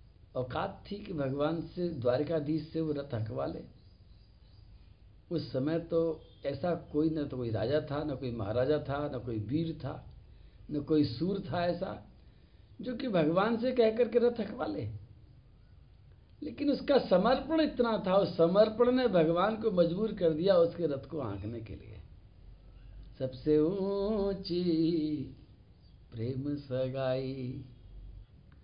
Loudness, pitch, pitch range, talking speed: -32 LUFS, 150 Hz, 115-175 Hz, 140 wpm